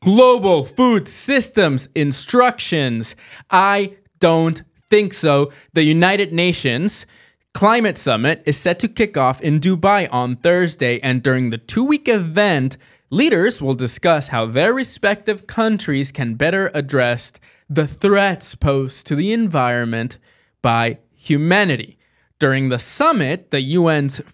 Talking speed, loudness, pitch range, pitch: 125 wpm, -17 LUFS, 135-200 Hz, 155 Hz